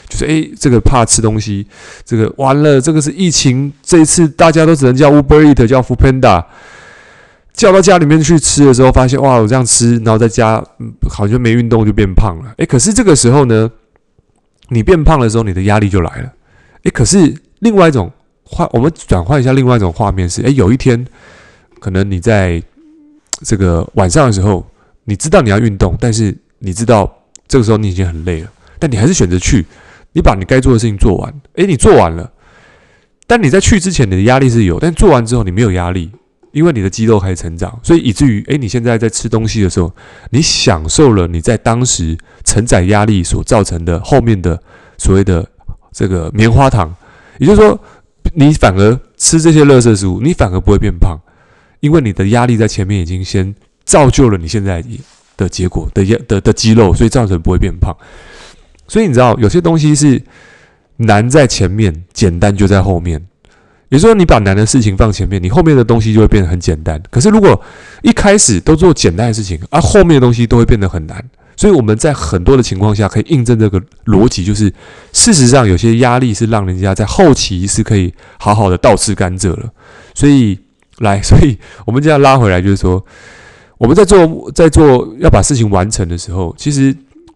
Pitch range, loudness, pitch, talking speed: 100-135 Hz, -10 LUFS, 115 Hz, 315 characters per minute